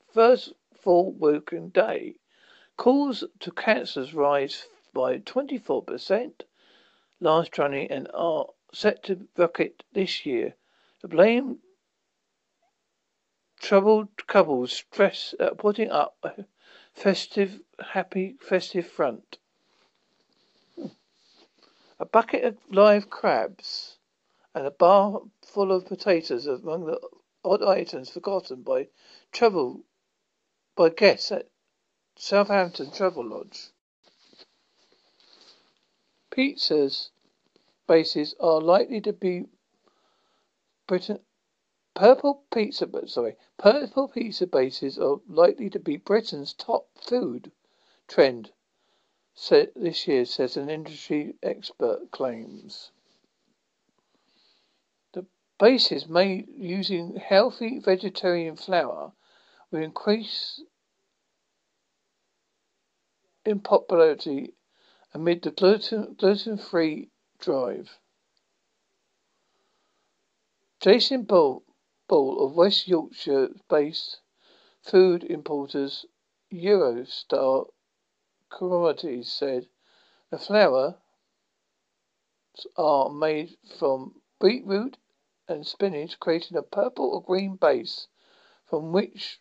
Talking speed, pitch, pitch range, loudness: 85 wpm, 205 Hz, 175-290 Hz, -24 LUFS